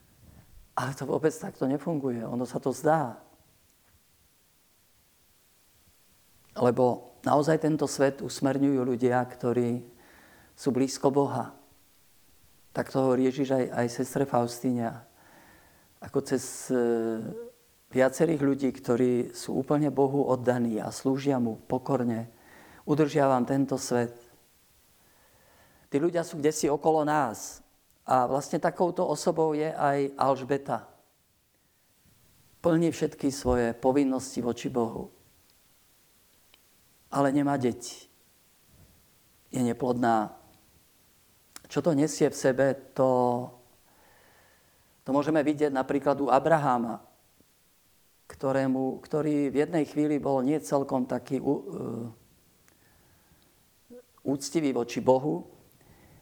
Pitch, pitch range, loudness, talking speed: 135 Hz, 125-145 Hz, -28 LUFS, 100 wpm